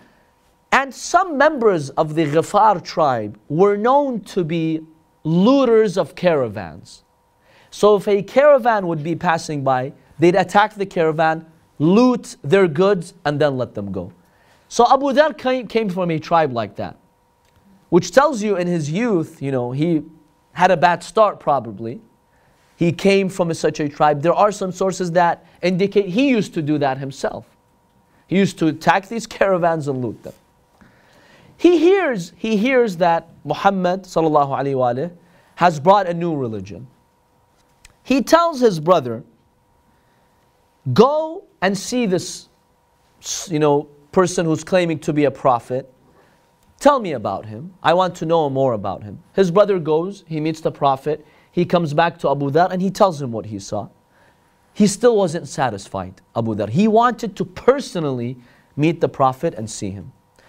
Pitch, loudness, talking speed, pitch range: 170 Hz, -18 LUFS, 160 wpm, 150-205 Hz